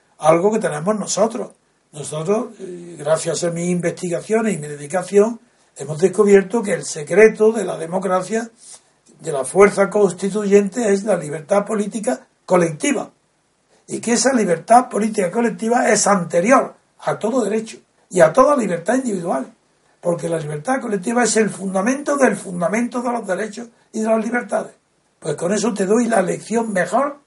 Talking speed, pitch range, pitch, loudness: 150 wpm, 180-230 Hz, 205 Hz, -18 LUFS